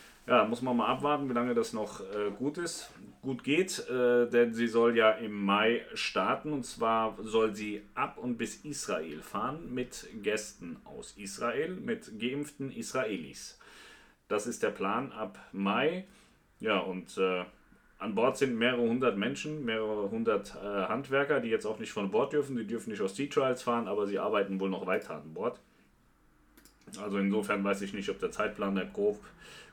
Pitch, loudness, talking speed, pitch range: 115 Hz, -32 LUFS, 180 wpm, 105-135 Hz